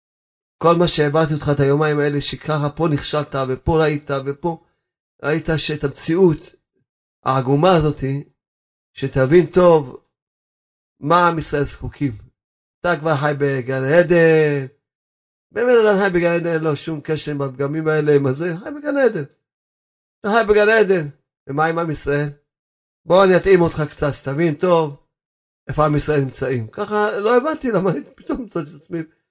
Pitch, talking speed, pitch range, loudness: 155 Hz, 145 wpm, 140-170 Hz, -18 LUFS